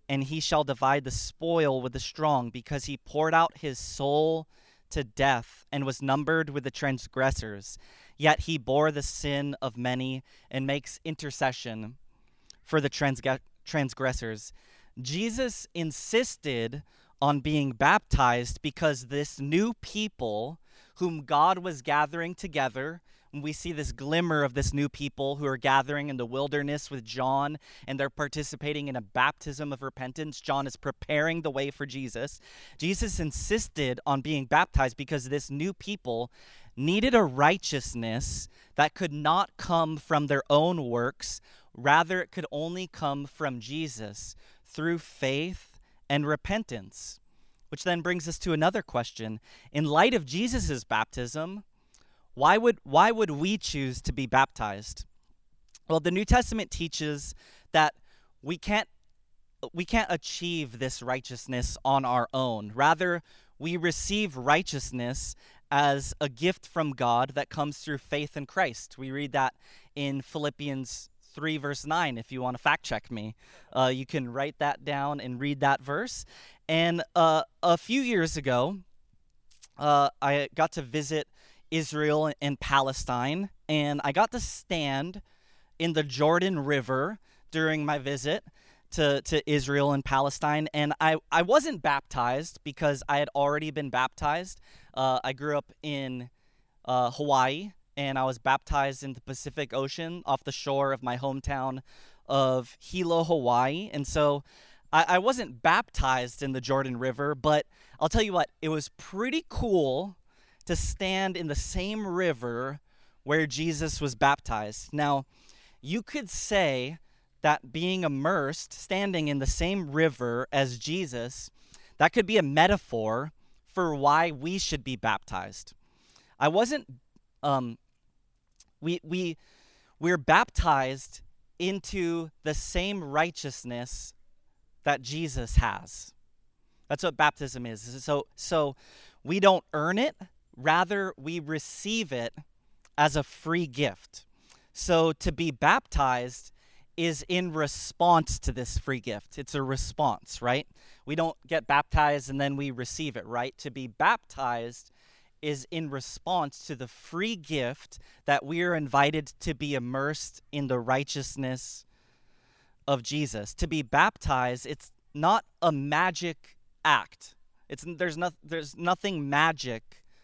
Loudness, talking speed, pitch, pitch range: -29 LUFS, 140 wpm, 145 Hz, 130-165 Hz